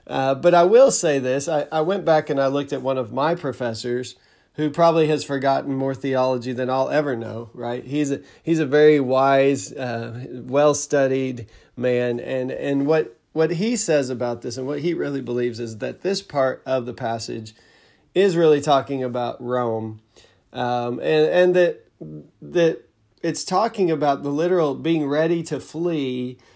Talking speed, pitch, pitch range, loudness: 175 wpm, 135 Hz, 125-155 Hz, -21 LUFS